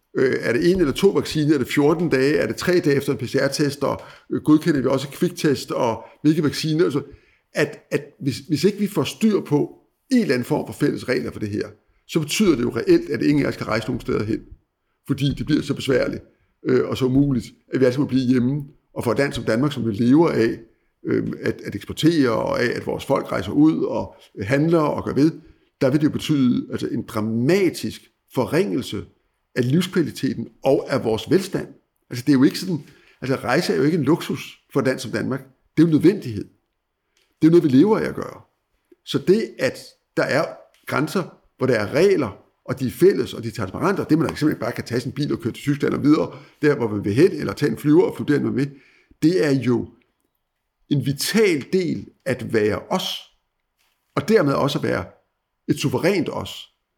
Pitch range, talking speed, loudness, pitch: 130-165 Hz, 220 wpm, -21 LUFS, 145 Hz